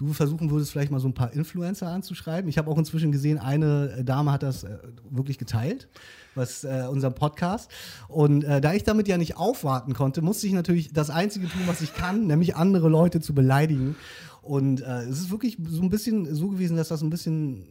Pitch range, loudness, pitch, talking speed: 135-175 Hz, -25 LUFS, 155 Hz, 210 wpm